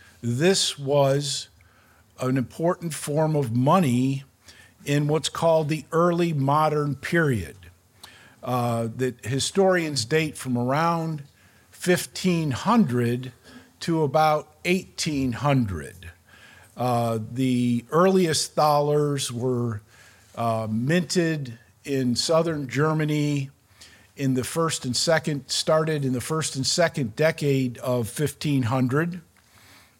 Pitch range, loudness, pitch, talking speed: 120-155 Hz, -24 LUFS, 140 Hz, 95 wpm